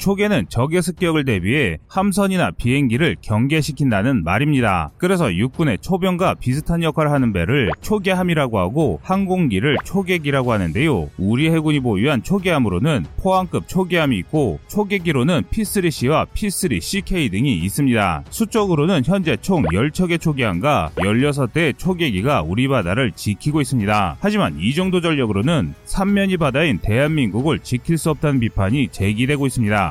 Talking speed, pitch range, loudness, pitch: 360 characters per minute, 120-185 Hz, -18 LUFS, 150 Hz